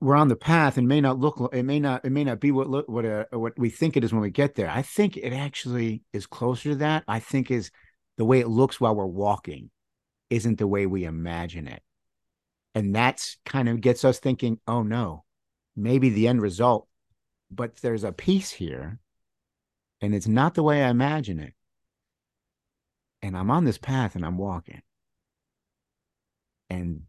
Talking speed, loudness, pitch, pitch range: 190 wpm, -25 LUFS, 120 Hz, 105-135 Hz